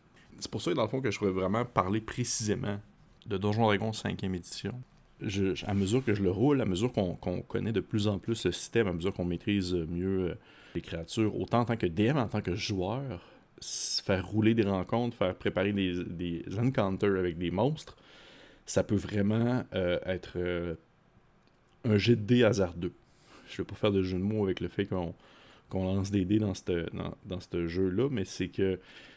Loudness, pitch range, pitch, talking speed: -31 LUFS, 90-110 Hz, 100 Hz, 200 wpm